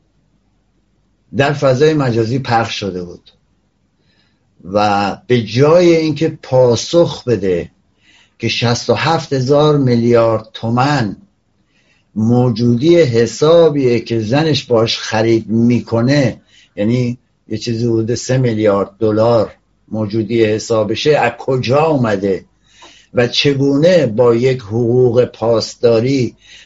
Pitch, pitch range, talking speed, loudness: 120 Hz, 110-135 Hz, 95 wpm, -14 LUFS